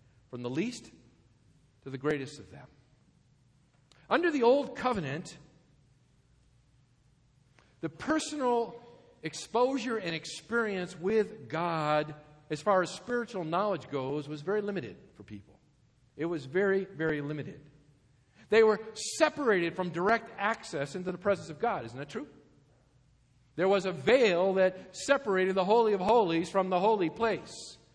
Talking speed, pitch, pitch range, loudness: 135 wpm, 165 Hz, 140-205 Hz, -30 LUFS